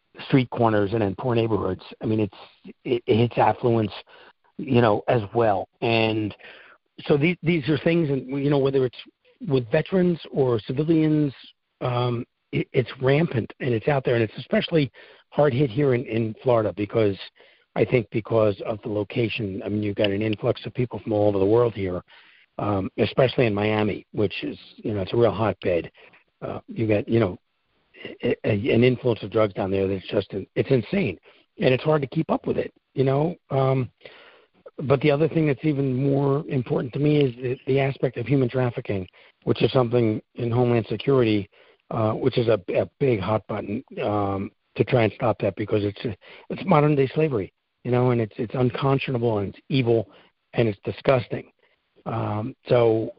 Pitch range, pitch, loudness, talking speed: 110-140 Hz, 125 Hz, -23 LUFS, 185 wpm